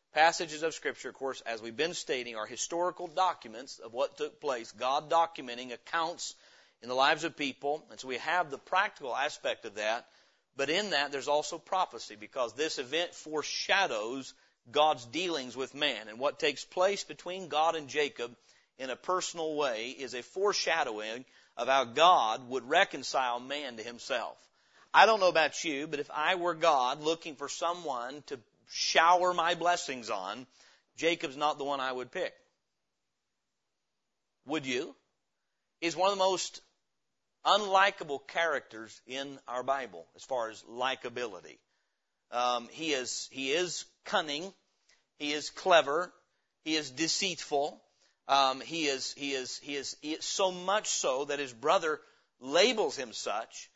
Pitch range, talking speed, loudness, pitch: 130-175 Hz, 155 wpm, -31 LUFS, 150 Hz